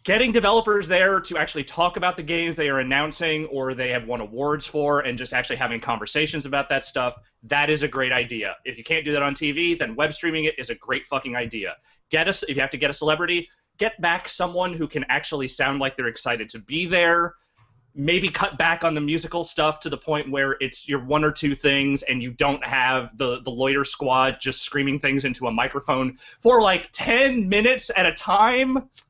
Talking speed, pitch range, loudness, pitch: 220 wpm, 130-170 Hz, -22 LUFS, 145 Hz